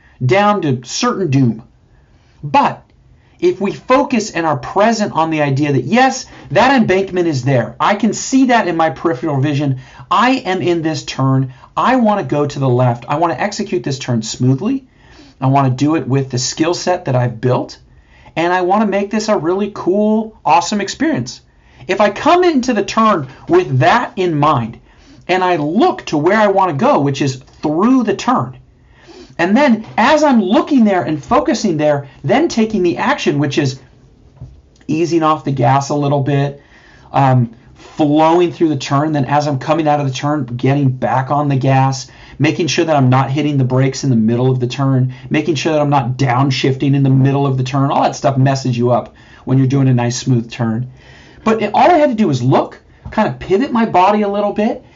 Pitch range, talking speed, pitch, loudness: 135-200 Hz, 205 wpm, 150 Hz, -14 LUFS